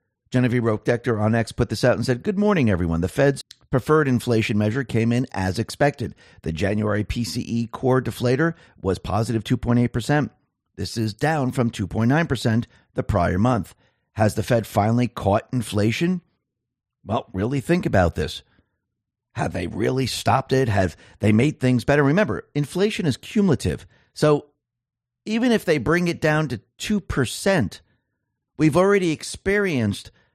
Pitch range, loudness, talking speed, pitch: 105-145 Hz, -22 LUFS, 145 wpm, 120 Hz